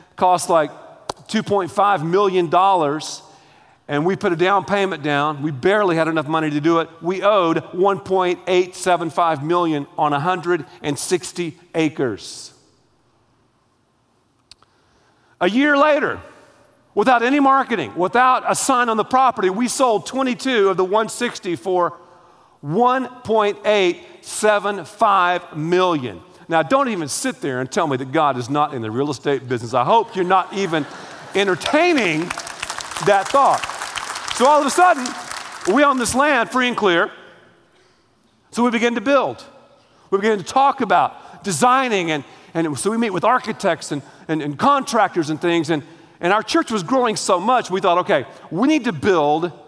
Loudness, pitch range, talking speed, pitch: -18 LUFS, 160-235 Hz, 150 wpm, 185 Hz